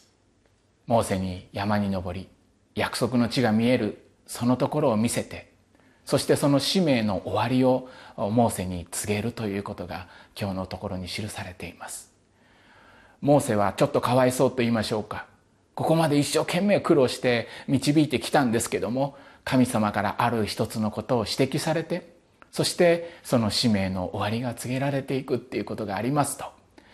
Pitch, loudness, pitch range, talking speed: 115 Hz, -25 LUFS, 105-135 Hz, 345 characters per minute